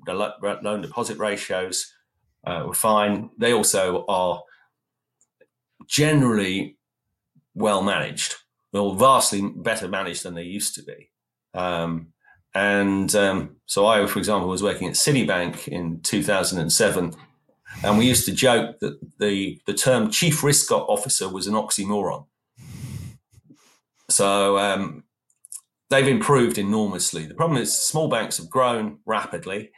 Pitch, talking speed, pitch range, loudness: 100 Hz, 130 wpm, 95-110 Hz, -22 LUFS